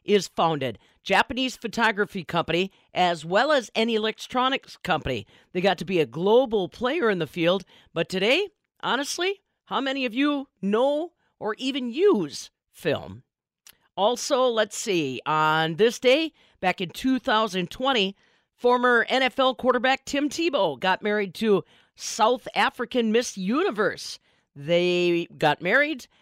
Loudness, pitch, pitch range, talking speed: -24 LUFS, 225 Hz, 185-260 Hz, 130 wpm